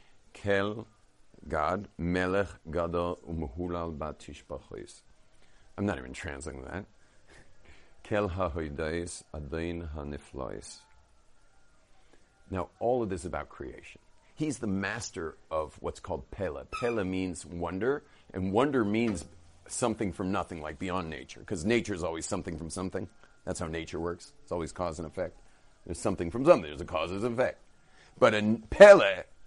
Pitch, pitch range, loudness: 90 Hz, 85-100 Hz, -30 LUFS